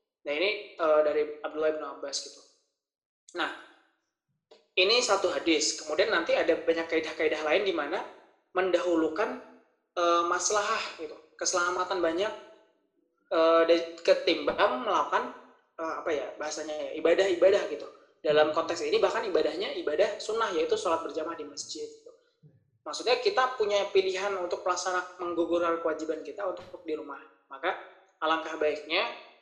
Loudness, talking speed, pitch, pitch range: -28 LUFS, 130 wpm, 180 Hz, 160-210 Hz